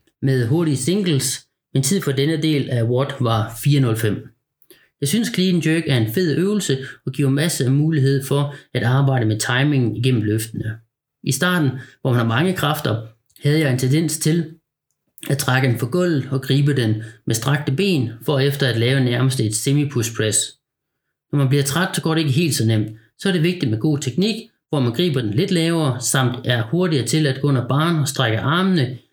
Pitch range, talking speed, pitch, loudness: 125-155 Hz, 205 wpm, 140 Hz, -19 LUFS